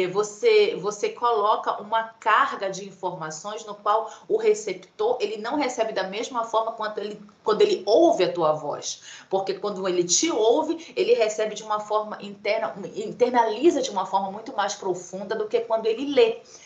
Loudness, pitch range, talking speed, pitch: -24 LUFS, 200-275 Hz, 170 wpm, 220 Hz